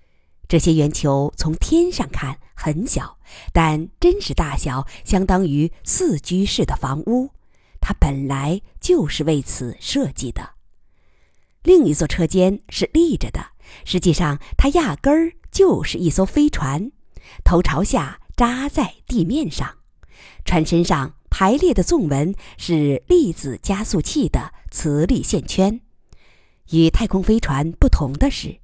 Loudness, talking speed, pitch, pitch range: -19 LUFS, 195 characters per minute, 170 Hz, 150-240 Hz